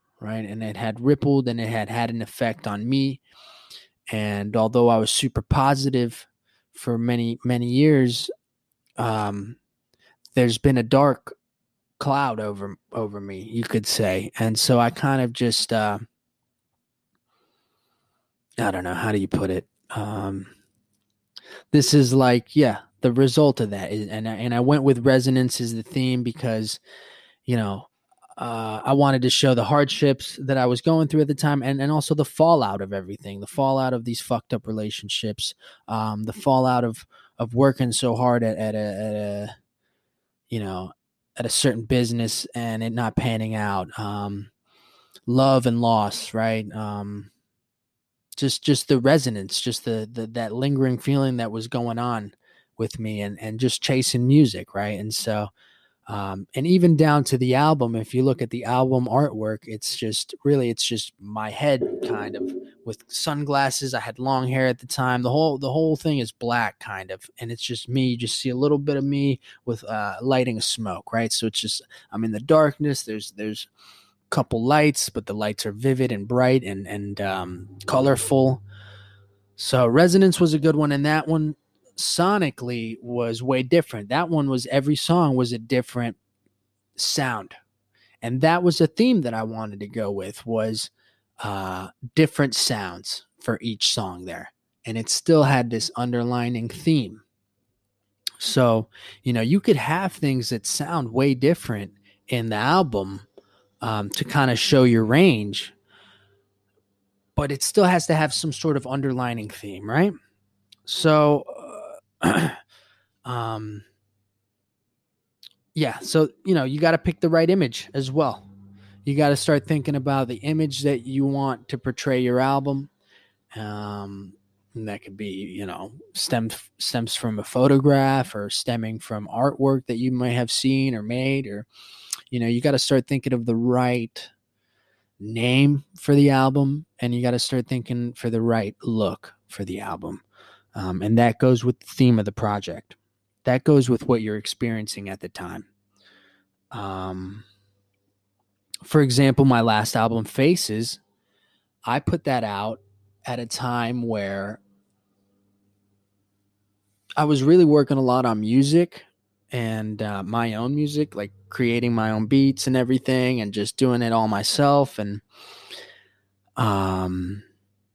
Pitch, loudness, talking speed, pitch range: 120 Hz, -22 LUFS, 165 wpm, 105-135 Hz